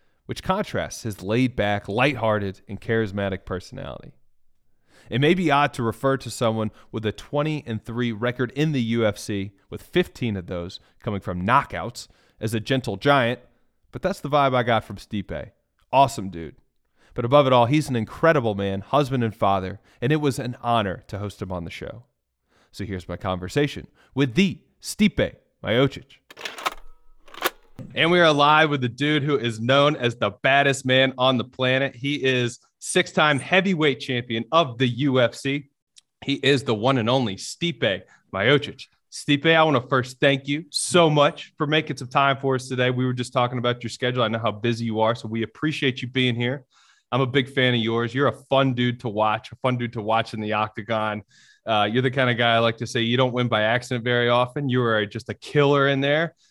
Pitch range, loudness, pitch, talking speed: 110-140 Hz, -22 LUFS, 125 Hz, 200 wpm